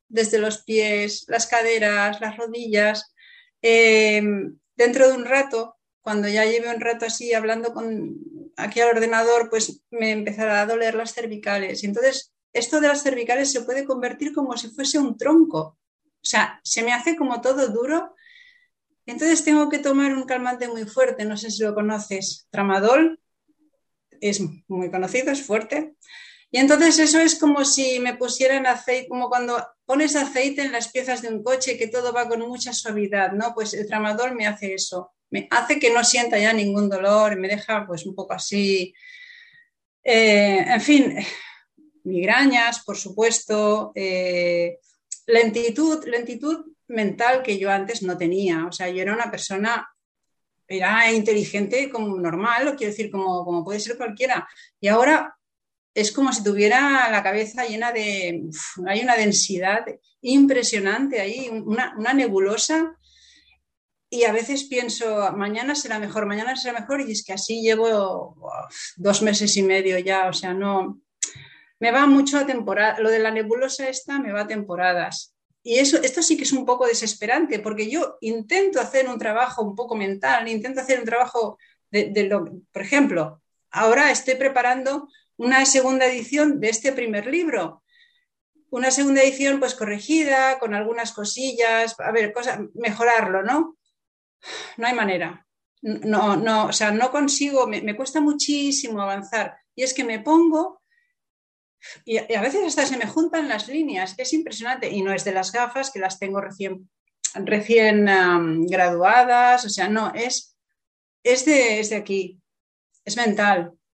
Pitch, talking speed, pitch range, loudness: 230 Hz, 165 wpm, 210-265 Hz, -21 LUFS